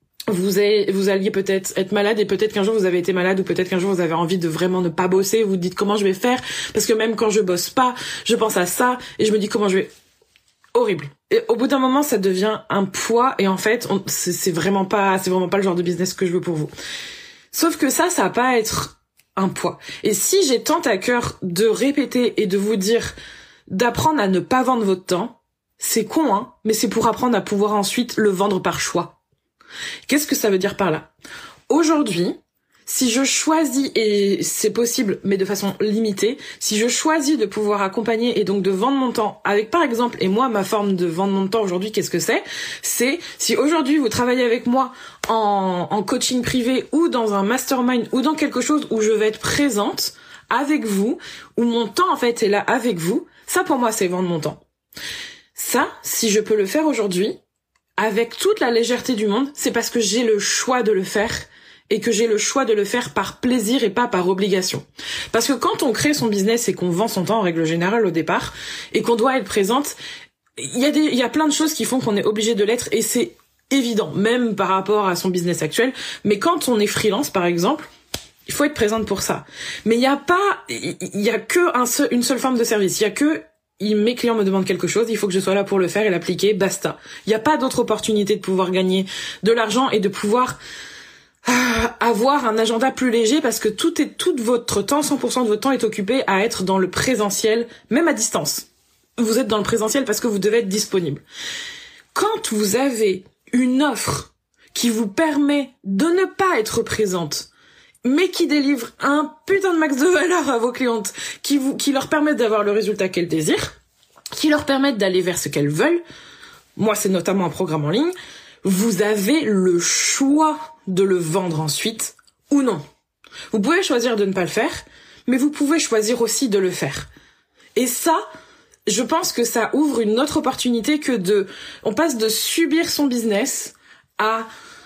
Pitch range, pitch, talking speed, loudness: 195-265 Hz, 225 Hz, 220 wpm, -19 LUFS